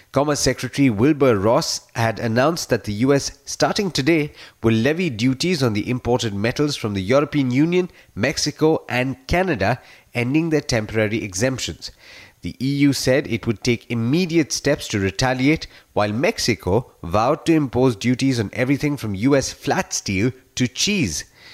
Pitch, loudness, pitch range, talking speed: 130 Hz, -20 LUFS, 115-145 Hz, 150 wpm